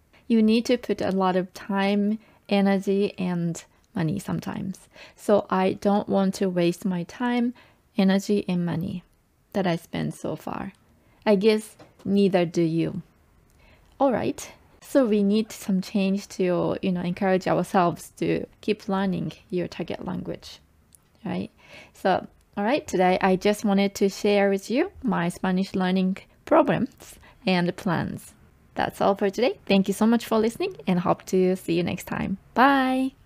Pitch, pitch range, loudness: 195 Hz, 185-210 Hz, -24 LUFS